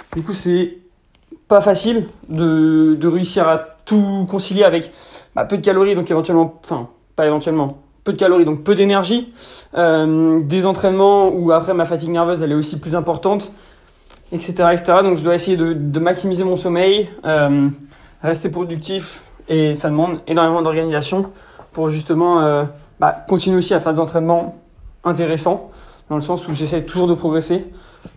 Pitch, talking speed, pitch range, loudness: 170 Hz, 165 wpm, 160-190 Hz, -16 LUFS